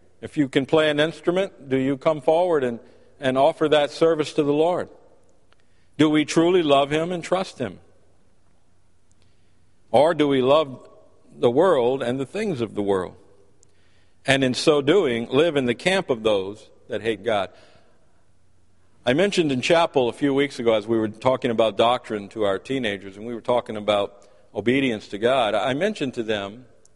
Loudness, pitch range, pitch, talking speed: -22 LUFS, 100-150 Hz, 120 Hz, 180 wpm